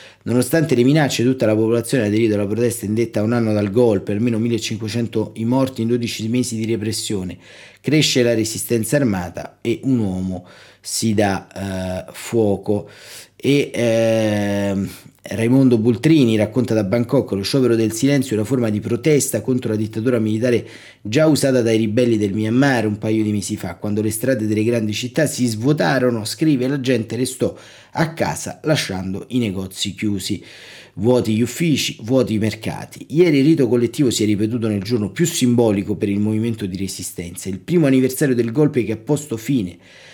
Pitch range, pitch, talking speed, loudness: 105-125 Hz, 115 Hz, 175 wpm, -19 LUFS